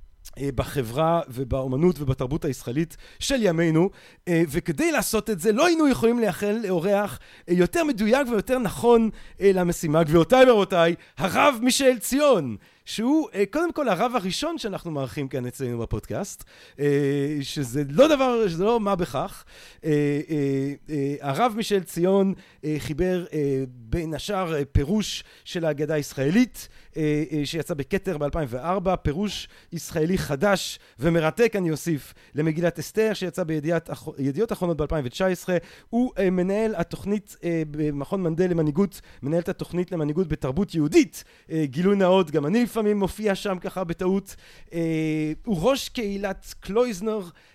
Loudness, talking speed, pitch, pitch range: -24 LUFS, 115 wpm, 175 Hz, 150-205 Hz